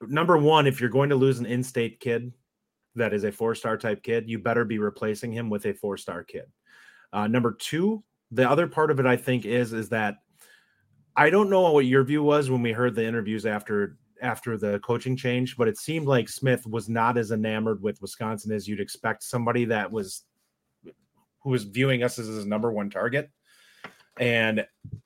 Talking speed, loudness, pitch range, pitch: 195 wpm, -25 LUFS, 110-130 Hz, 120 Hz